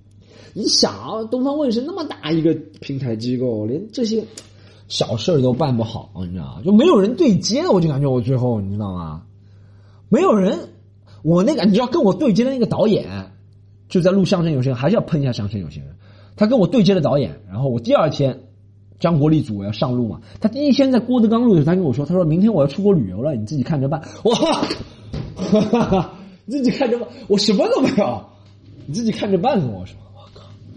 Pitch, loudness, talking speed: 145 Hz, -18 LUFS, 325 characters per minute